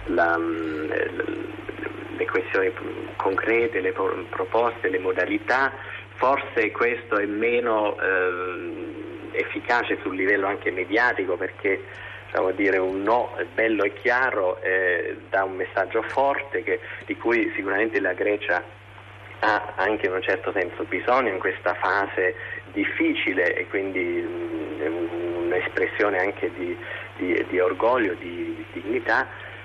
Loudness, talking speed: -24 LUFS, 120 wpm